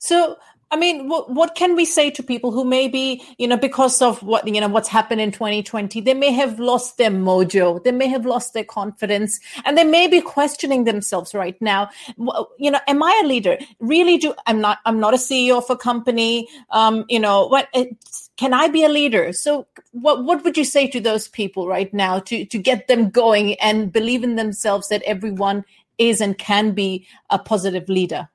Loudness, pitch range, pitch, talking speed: -18 LUFS, 210-270 Hz, 235 Hz, 205 wpm